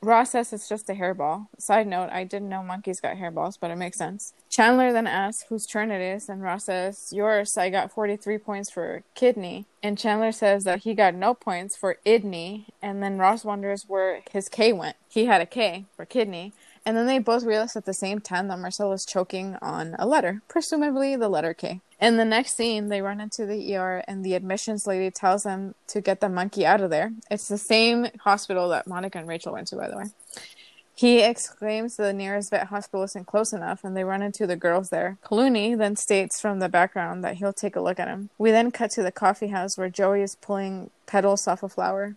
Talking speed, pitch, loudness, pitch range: 225 wpm, 200 Hz, -25 LUFS, 190-220 Hz